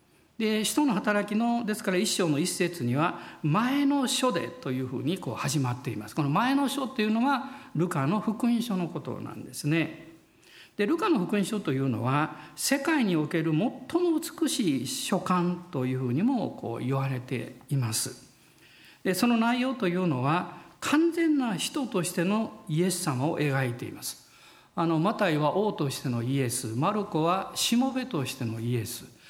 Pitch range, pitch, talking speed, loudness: 140-235 Hz, 175 Hz, 315 characters per minute, -28 LUFS